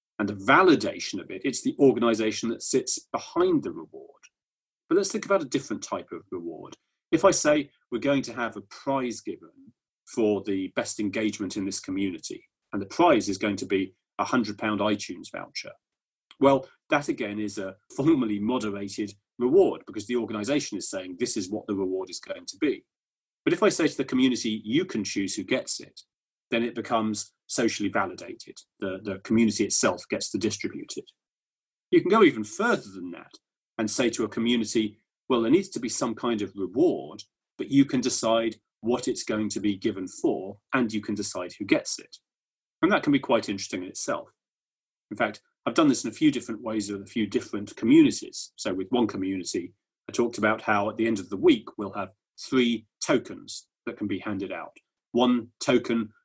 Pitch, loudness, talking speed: 120 Hz, -26 LUFS, 195 wpm